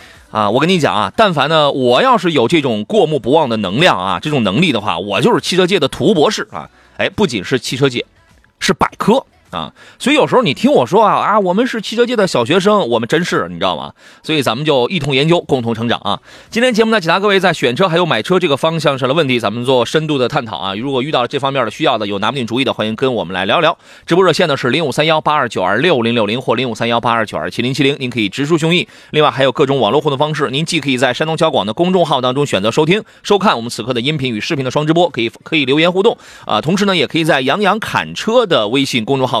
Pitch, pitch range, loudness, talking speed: 145 Hz, 120-175 Hz, -14 LUFS, 405 characters per minute